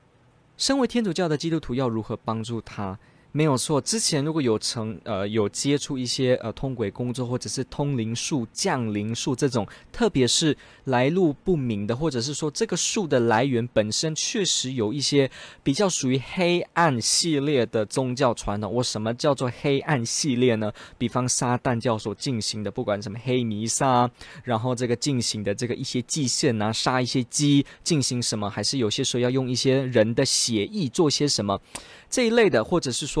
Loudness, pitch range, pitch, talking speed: -24 LUFS, 115-145 Hz, 125 Hz, 285 characters per minute